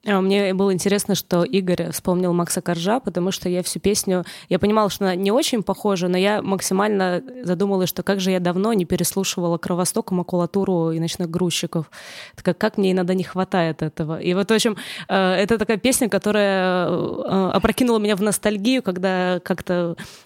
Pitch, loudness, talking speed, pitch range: 190 Hz, -21 LUFS, 170 wpm, 180-205 Hz